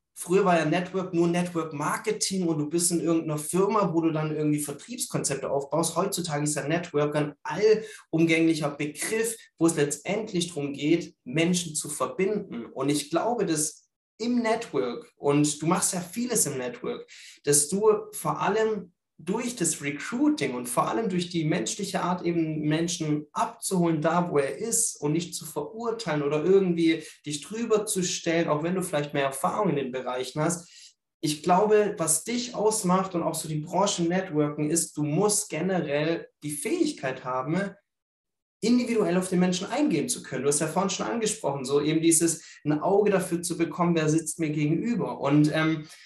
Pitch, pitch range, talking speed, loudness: 165 Hz, 150-195 Hz, 170 wpm, -26 LUFS